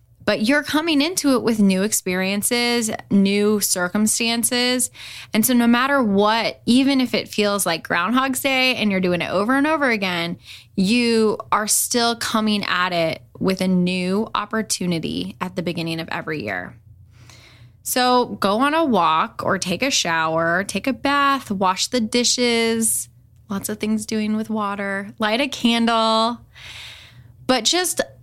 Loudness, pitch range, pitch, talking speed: -19 LUFS, 180-245 Hz, 215 Hz, 155 wpm